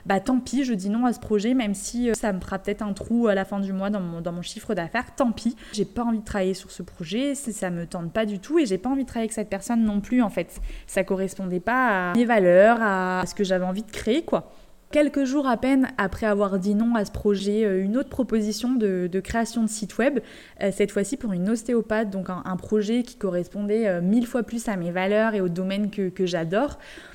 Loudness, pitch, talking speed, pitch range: -24 LUFS, 210 Hz, 255 wpm, 195-235 Hz